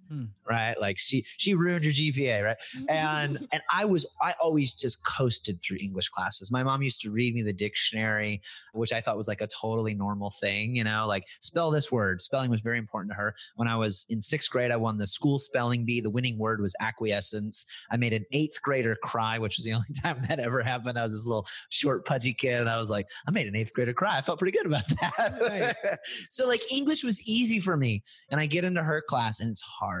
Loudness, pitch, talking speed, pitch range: -28 LUFS, 120 Hz, 235 wpm, 110-145 Hz